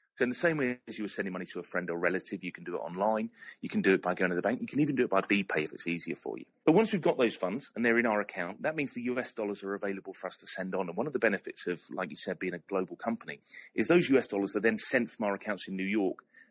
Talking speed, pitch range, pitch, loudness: 325 wpm, 95-125 Hz, 105 Hz, -32 LUFS